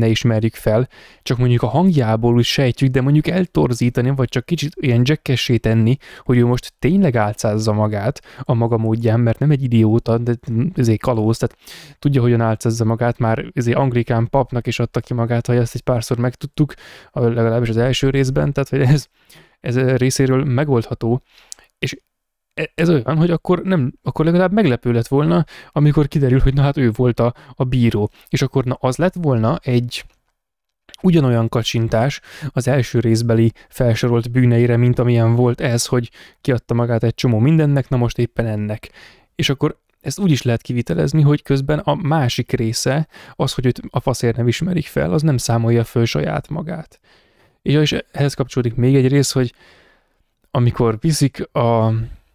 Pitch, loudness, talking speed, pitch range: 125 Hz, -17 LUFS, 170 wpm, 115-140 Hz